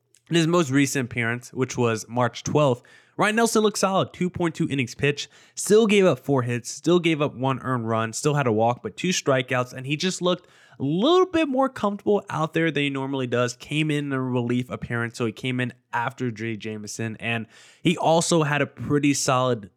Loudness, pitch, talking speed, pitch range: -23 LUFS, 140 Hz, 210 wpm, 120-170 Hz